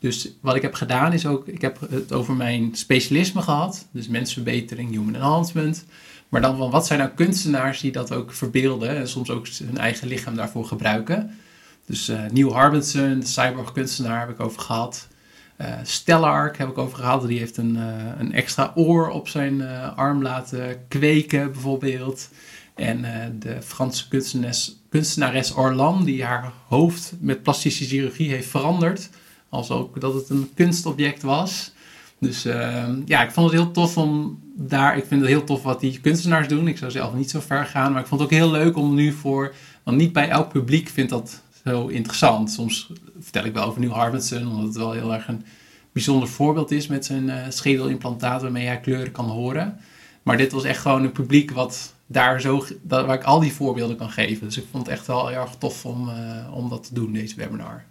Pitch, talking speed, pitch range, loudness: 130 Hz, 200 wpm, 120-145 Hz, -22 LUFS